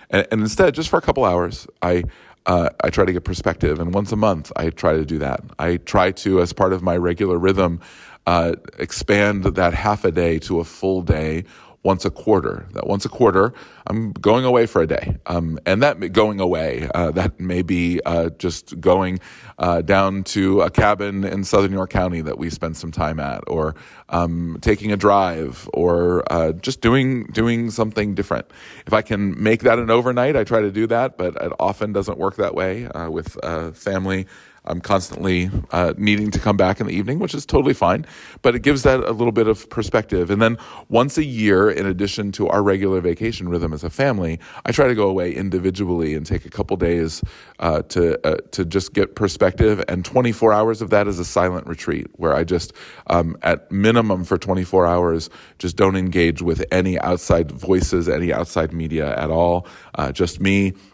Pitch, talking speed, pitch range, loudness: 95 Hz, 205 wpm, 85-105 Hz, -19 LUFS